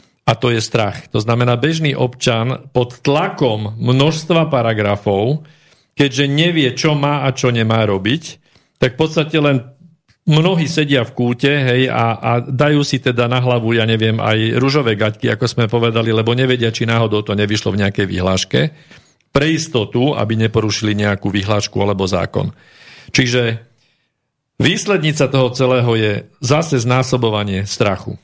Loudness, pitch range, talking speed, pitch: -16 LUFS, 110-145 Hz, 145 wpm, 125 Hz